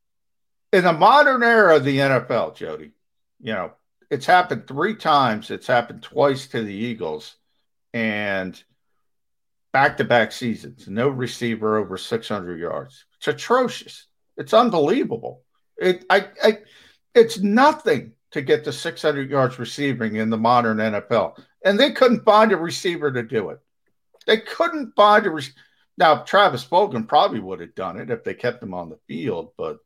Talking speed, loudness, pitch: 155 wpm, -20 LUFS, 145 Hz